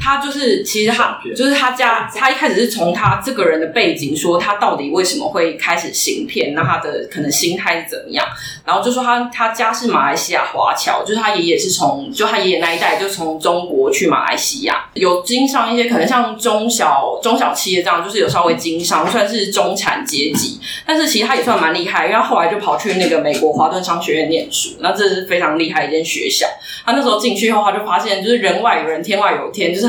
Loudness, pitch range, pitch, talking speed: -15 LUFS, 175-245 Hz, 215 Hz, 350 characters per minute